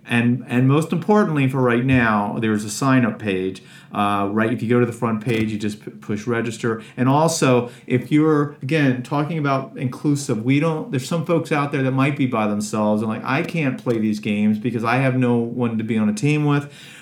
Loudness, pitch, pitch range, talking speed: -20 LUFS, 125 Hz, 110-145 Hz, 220 wpm